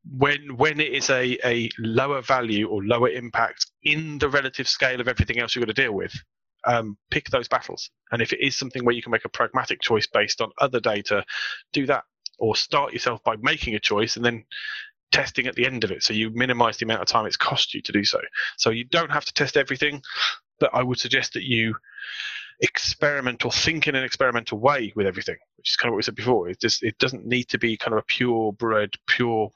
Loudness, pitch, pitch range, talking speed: -23 LUFS, 125 Hz, 115-140 Hz, 240 wpm